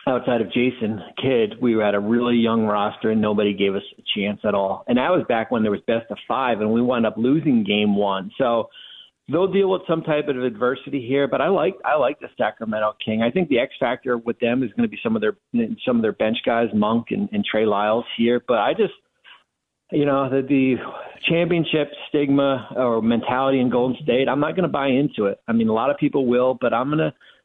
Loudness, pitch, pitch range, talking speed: -21 LUFS, 125 Hz, 110-150 Hz, 235 wpm